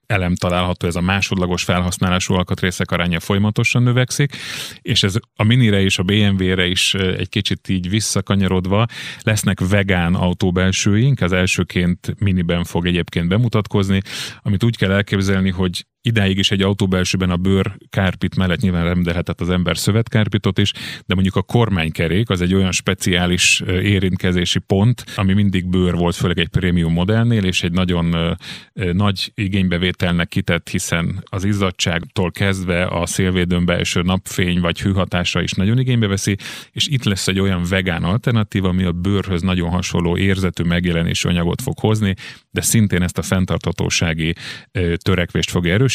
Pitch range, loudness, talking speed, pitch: 90-100 Hz, -18 LUFS, 150 wpm, 95 Hz